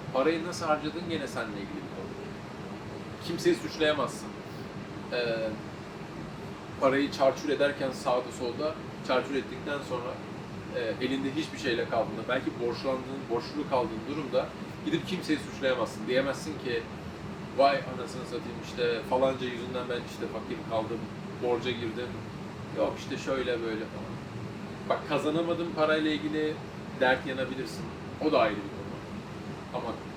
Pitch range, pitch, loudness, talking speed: 125-155 Hz, 140 Hz, -32 LUFS, 120 wpm